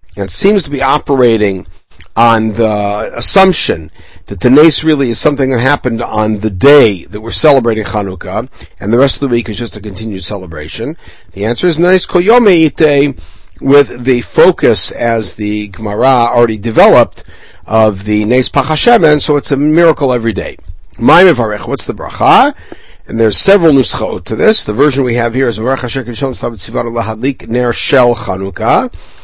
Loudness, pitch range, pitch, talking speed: -10 LUFS, 105-140 Hz, 120 Hz, 160 wpm